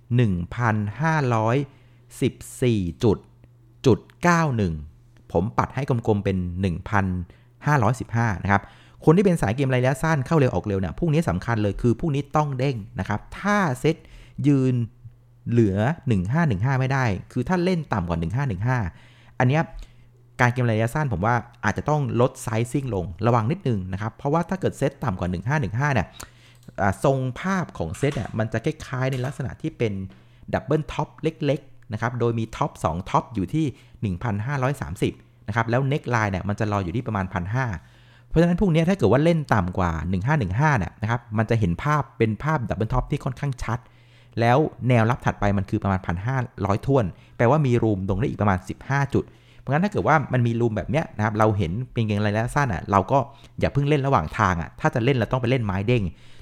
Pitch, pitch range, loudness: 120 Hz, 105-140 Hz, -23 LUFS